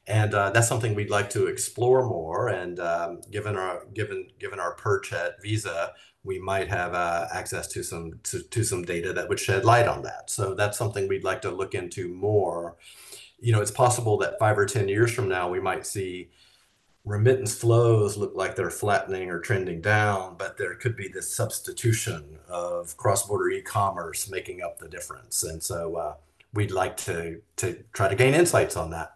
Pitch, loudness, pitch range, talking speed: 105 Hz, -26 LUFS, 90-120 Hz, 195 wpm